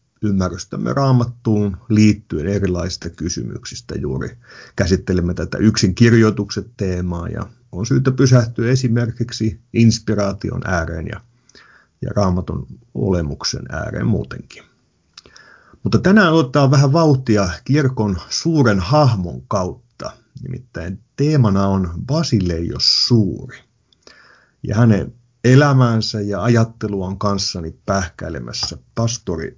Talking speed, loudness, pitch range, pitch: 95 wpm, -17 LUFS, 95-125 Hz, 110 Hz